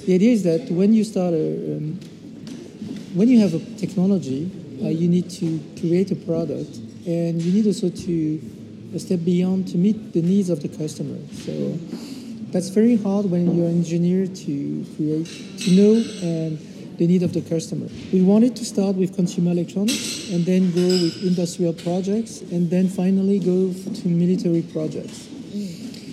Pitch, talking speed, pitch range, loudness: 180 Hz, 170 wpm, 170-200 Hz, -21 LUFS